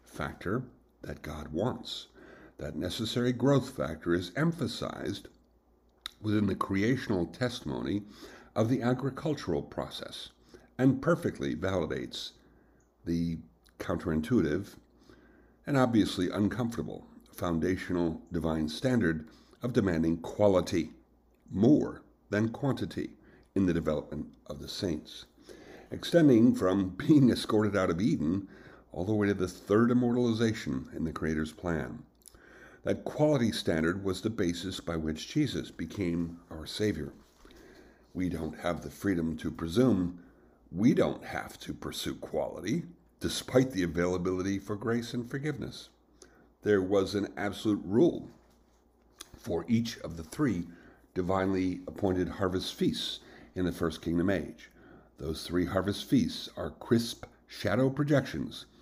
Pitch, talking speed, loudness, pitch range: 95 Hz, 120 wpm, -31 LUFS, 85-115 Hz